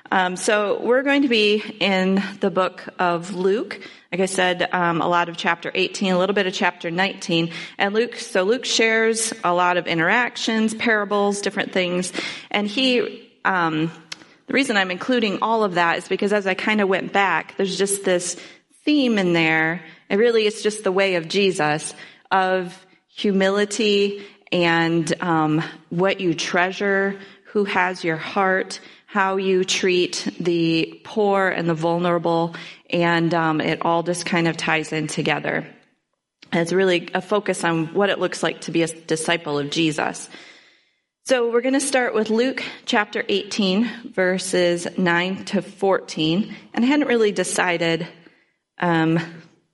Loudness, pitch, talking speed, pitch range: -21 LUFS, 185 Hz, 160 wpm, 170-205 Hz